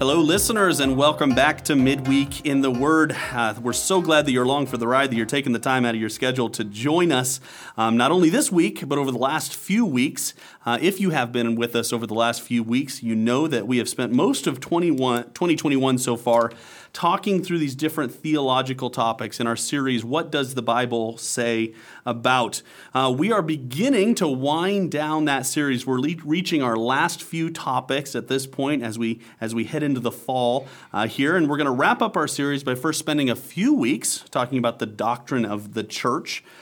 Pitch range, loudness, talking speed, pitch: 120-155 Hz, -22 LUFS, 215 wpm, 130 Hz